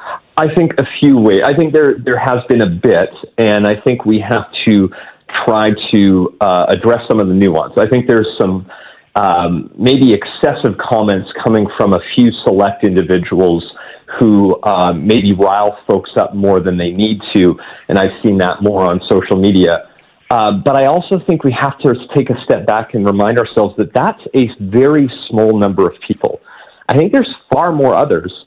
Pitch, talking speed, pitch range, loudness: 105 Hz, 190 wpm, 95-125 Hz, -12 LUFS